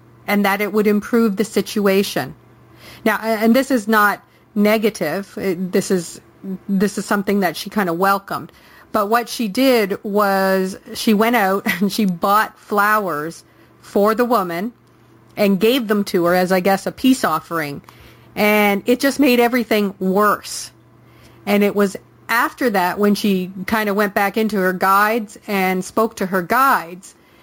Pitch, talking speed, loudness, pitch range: 205 Hz, 160 wpm, -17 LUFS, 185-220 Hz